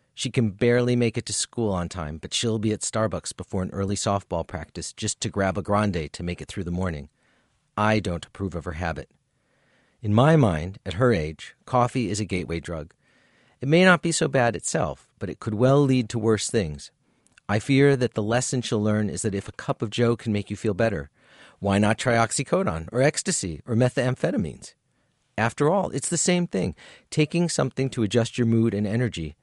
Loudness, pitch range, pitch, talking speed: -24 LUFS, 95-125 Hz, 110 Hz, 210 wpm